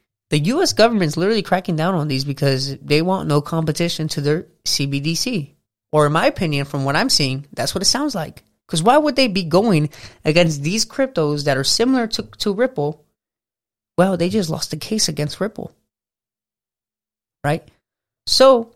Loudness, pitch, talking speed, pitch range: -18 LUFS, 165 Hz, 175 wpm, 145-205 Hz